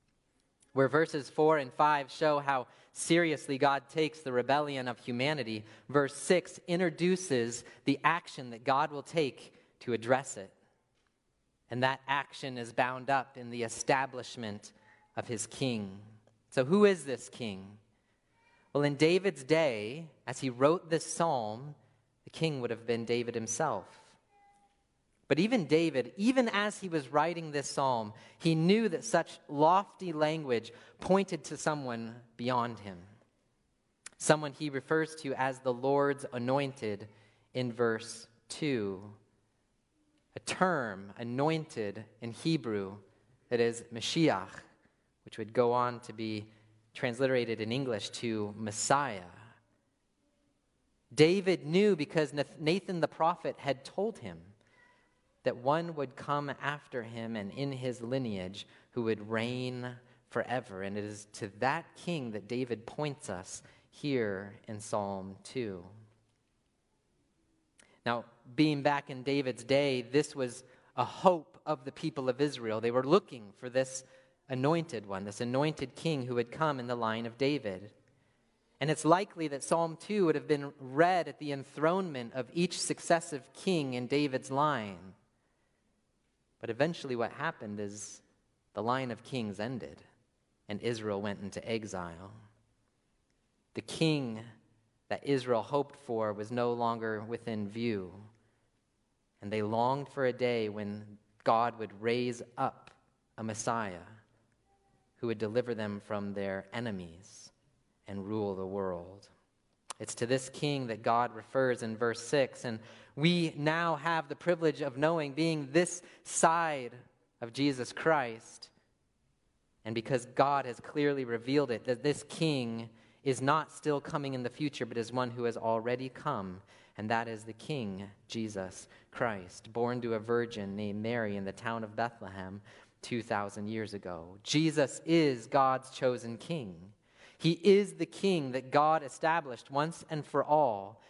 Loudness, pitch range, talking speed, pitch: -33 LUFS, 110-150 Hz, 140 wpm, 125 Hz